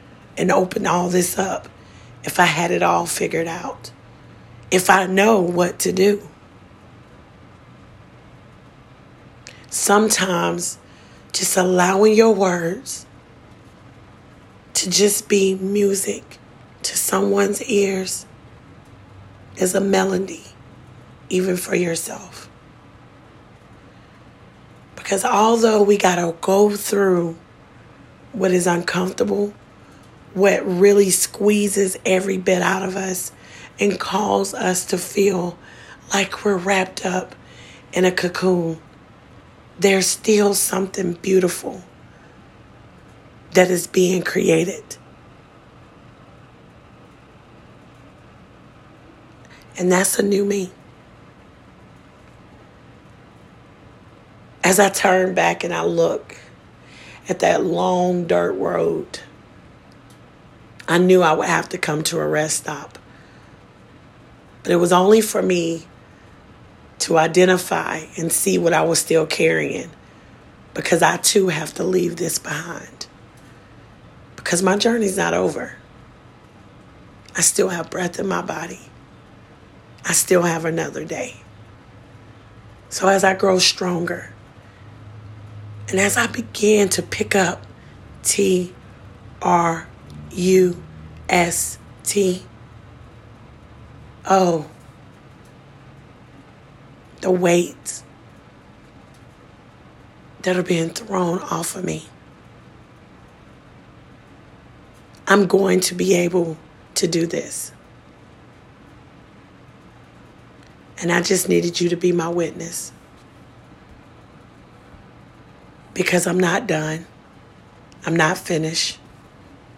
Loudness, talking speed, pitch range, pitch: -19 LUFS, 95 wpm, 130-190 Hz, 180 Hz